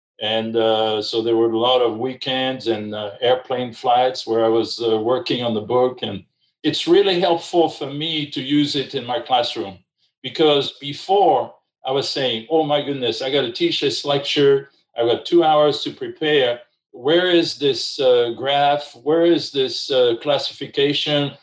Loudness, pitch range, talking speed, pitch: -19 LUFS, 125-170 Hz, 175 wpm, 145 Hz